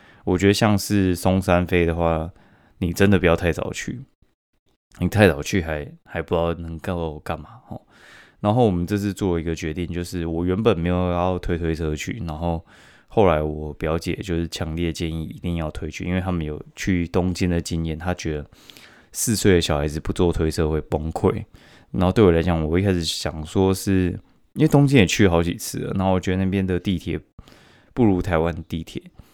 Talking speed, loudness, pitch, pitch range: 285 characters per minute, -22 LUFS, 85 Hz, 80-95 Hz